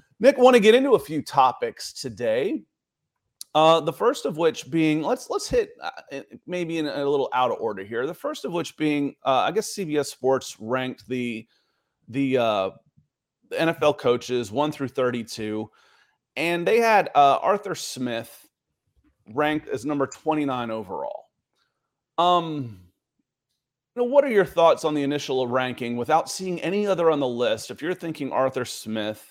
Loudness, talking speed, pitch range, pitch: -23 LUFS, 165 wpm, 130-170 Hz, 145 Hz